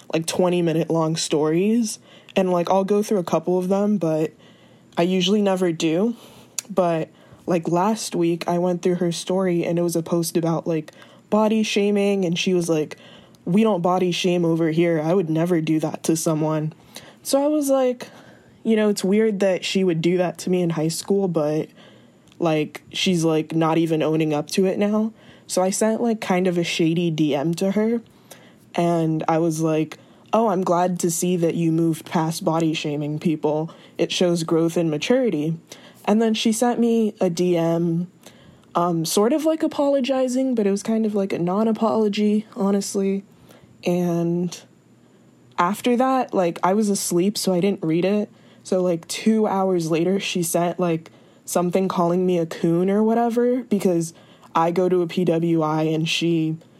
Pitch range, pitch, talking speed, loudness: 165-205 Hz, 180 Hz, 180 wpm, -21 LUFS